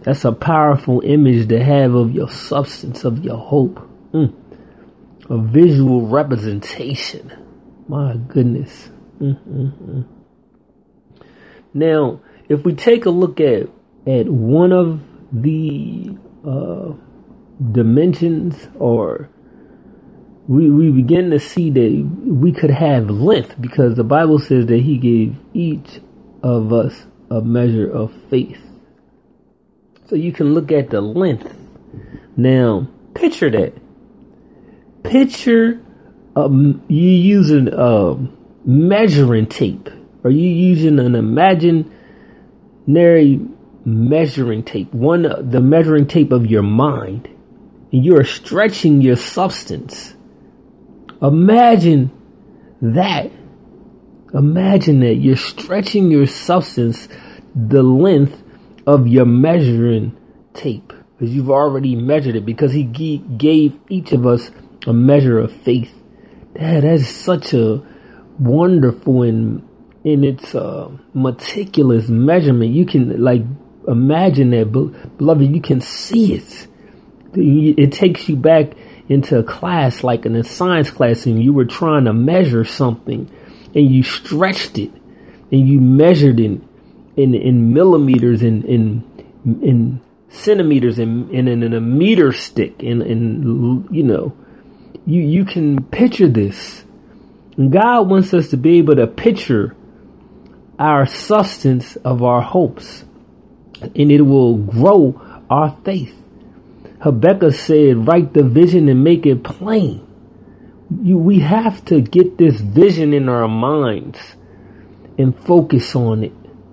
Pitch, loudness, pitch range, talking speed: 140 Hz, -14 LUFS, 120-165 Hz, 120 wpm